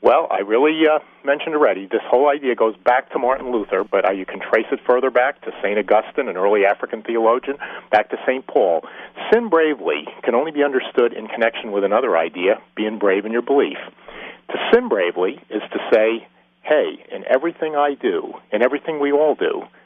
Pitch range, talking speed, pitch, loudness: 115-155 Hz, 195 wpm, 140 Hz, -19 LUFS